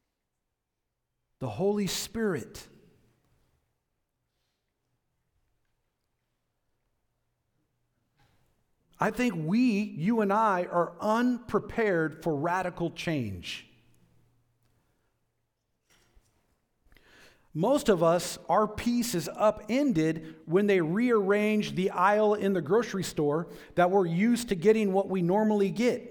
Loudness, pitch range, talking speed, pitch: -27 LUFS, 165-215 Hz, 90 wpm, 195 Hz